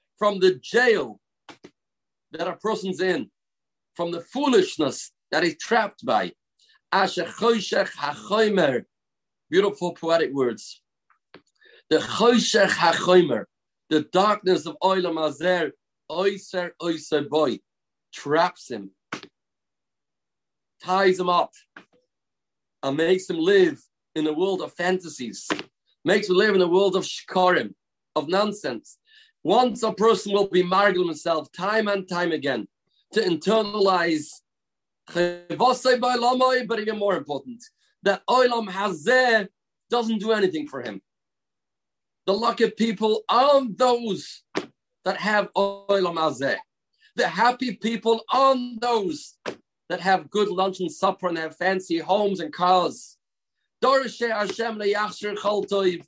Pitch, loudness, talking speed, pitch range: 200 Hz, -23 LUFS, 105 wpm, 180-235 Hz